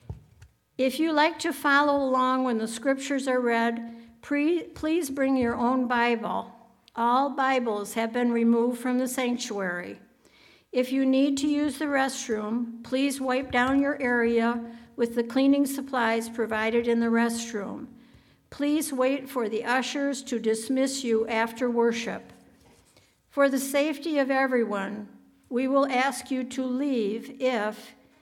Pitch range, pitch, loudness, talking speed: 230-270 Hz, 250 Hz, -26 LUFS, 140 wpm